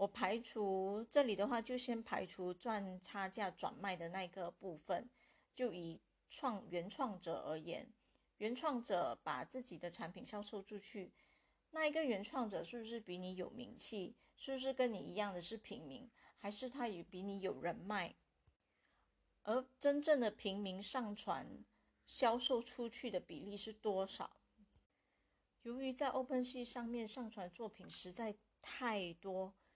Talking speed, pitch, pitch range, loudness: 230 characters per minute, 215 Hz, 190-245 Hz, -44 LUFS